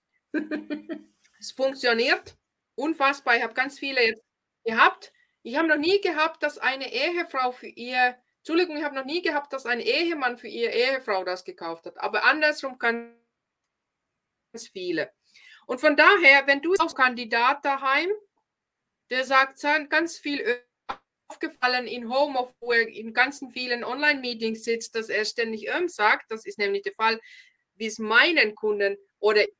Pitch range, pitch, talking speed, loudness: 235-315 Hz, 270 Hz, 155 wpm, -24 LUFS